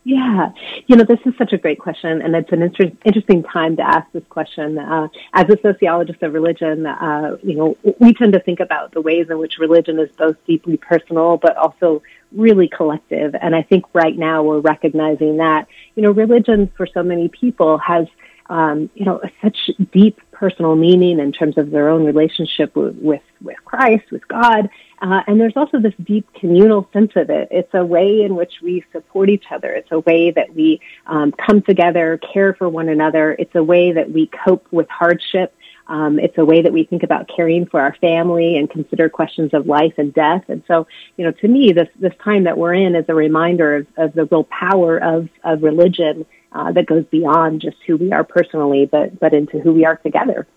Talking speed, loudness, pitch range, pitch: 210 wpm, -15 LUFS, 160-190 Hz, 170 Hz